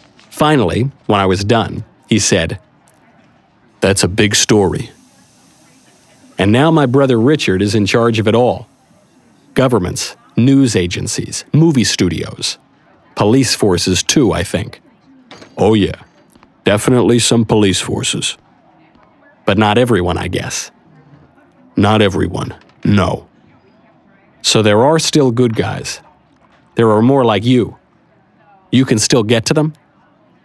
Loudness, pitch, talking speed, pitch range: -13 LUFS, 120 Hz, 125 wpm, 105-135 Hz